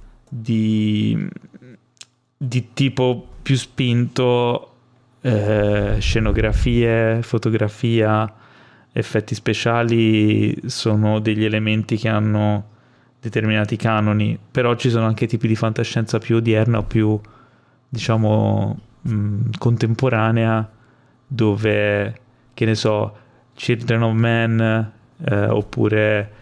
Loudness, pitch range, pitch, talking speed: -19 LUFS, 110-120 Hz, 115 Hz, 90 wpm